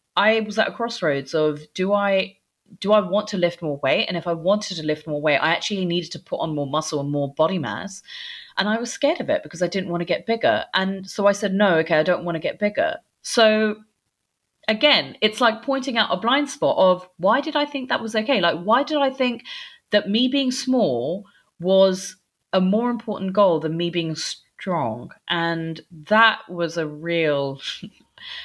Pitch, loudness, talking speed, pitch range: 195 Hz, -21 LUFS, 210 wpm, 170-230 Hz